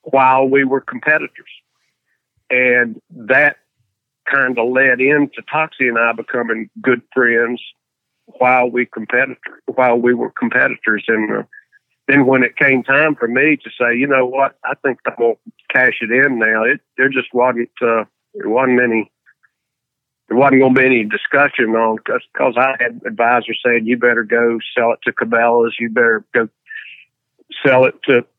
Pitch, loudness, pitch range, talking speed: 125 Hz, -15 LUFS, 115-135 Hz, 165 wpm